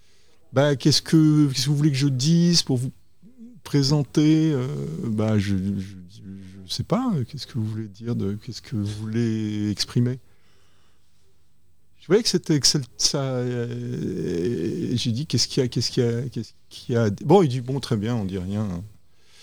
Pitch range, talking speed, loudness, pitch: 100-140 Hz, 185 wpm, -23 LUFS, 120 Hz